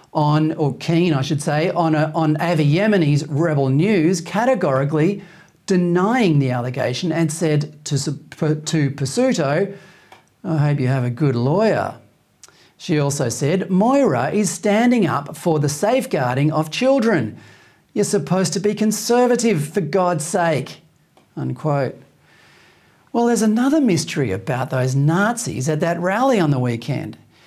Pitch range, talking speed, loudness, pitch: 145-195 Hz, 135 wpm, -19 LUFS, 160 Hz